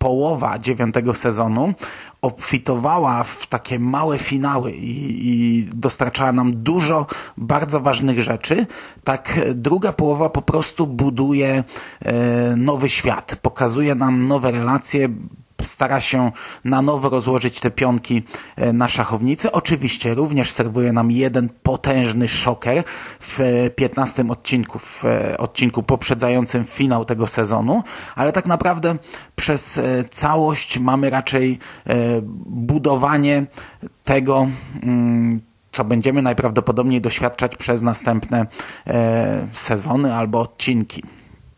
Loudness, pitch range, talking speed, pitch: -18 LUFS, 120-140 Hz, 105 wpm, 125 Hz